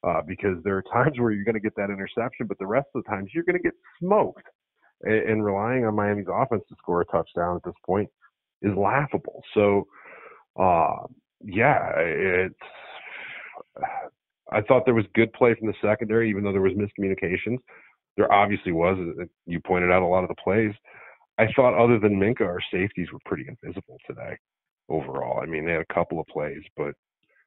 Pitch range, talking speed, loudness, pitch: 95-115 Hz, 190 wpm, -24 LUFS, 105 Hz